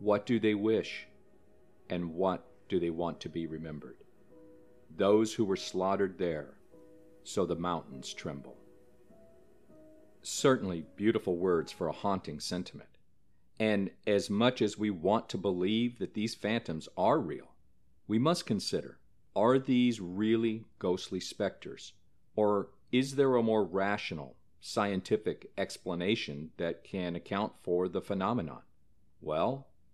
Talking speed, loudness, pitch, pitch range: 130 wpm, -32 LUFS, 100 Hz, 85-110 Hz